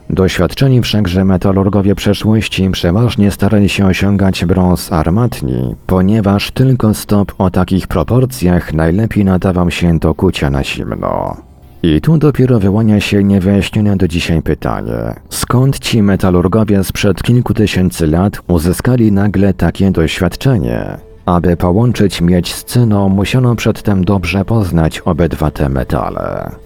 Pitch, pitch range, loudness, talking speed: 95 Hz, 90-105 Hz, -12 LUFS, 125 wpm